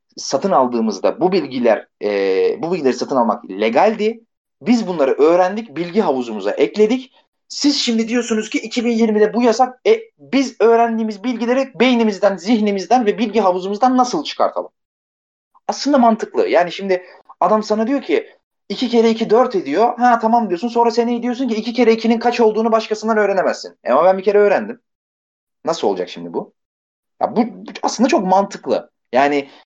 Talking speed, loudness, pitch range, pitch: 155 wpm, -17 LUFS, 210-250 Hz, 230 Hz